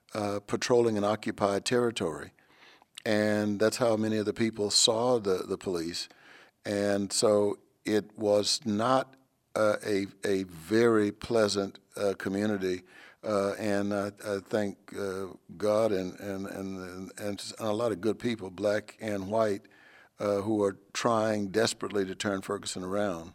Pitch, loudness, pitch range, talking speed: 105 Hz, -29 LUFS, 100-110 Hz, 145 wpm